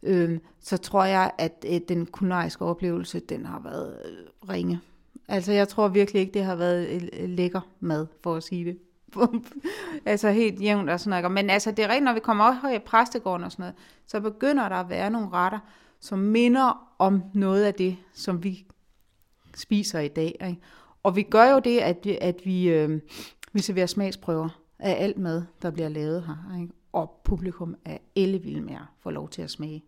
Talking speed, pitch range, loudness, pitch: 195 wpm, 170-205 Hz, -26 LUFS, 185 Hz